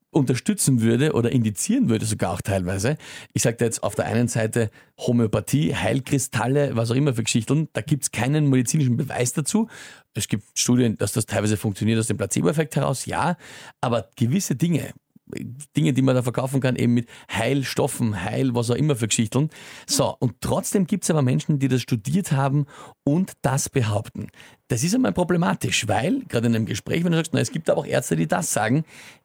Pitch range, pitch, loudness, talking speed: 115-145 Hz, 130 Hz, -23 LUFS, 195 wpm